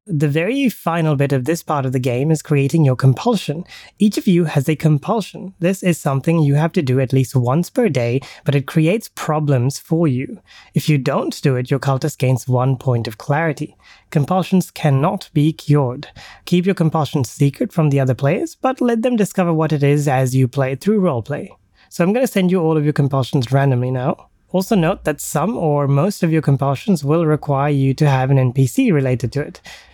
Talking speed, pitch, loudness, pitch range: 210 wpm, 150 Hz, -17 LUFS, 135-175 Hz